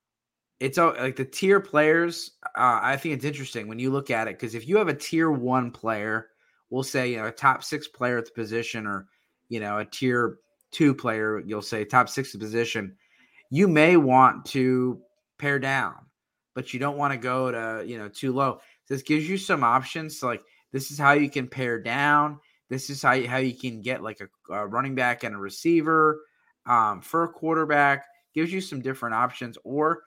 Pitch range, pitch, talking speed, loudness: 115-150 Hz, 130 Hz, 210 wpm, -25 LUFS